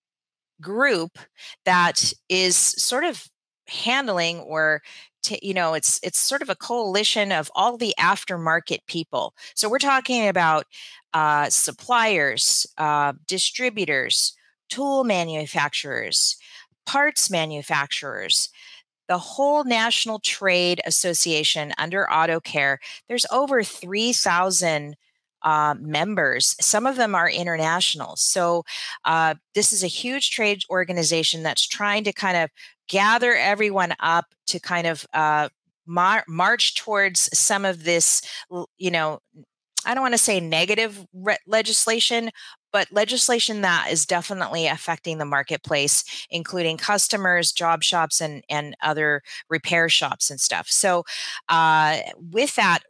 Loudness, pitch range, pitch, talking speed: -21 LUFS, 160-210 Hz, 175 Hz, 125 wpm